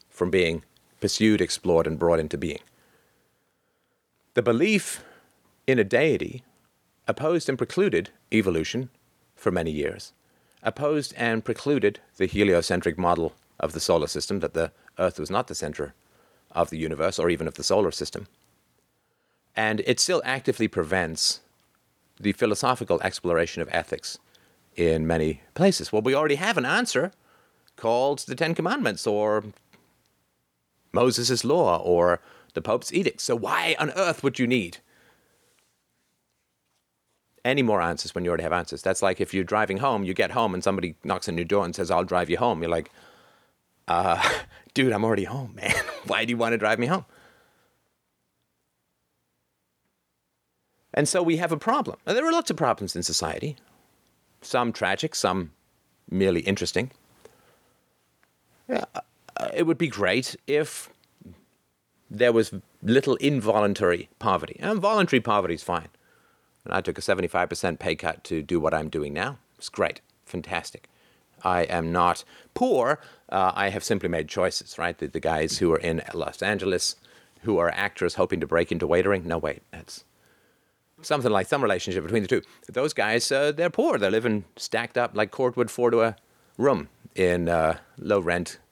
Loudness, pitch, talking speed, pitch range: -25 LUFS, 100 Hz, 160 wpm, 85-120 Hz